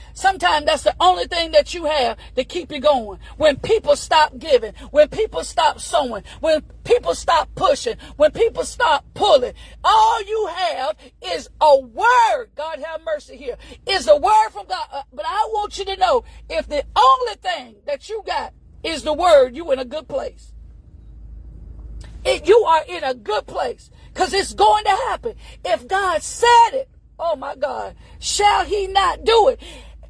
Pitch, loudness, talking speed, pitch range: 360 Hz, -18 LUFS, 175 wpm, 300-440 Hz